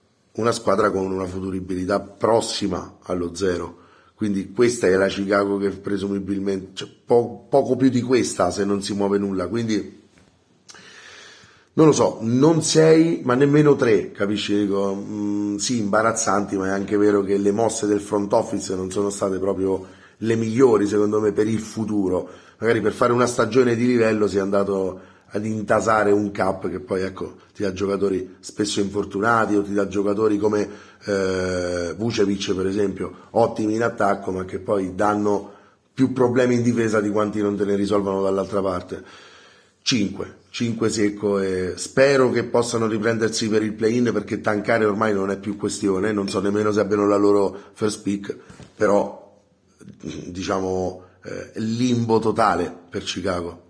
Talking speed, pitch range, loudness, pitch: 160 wpm, 95-110 Hz, -21 LUFS, 100 Hz